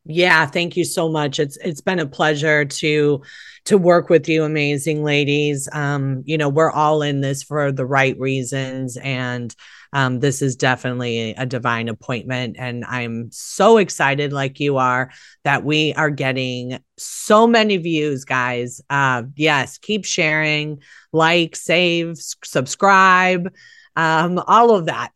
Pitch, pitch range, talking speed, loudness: 145 Hz, 130-165 Hz, 150 wpm, -18 LUFS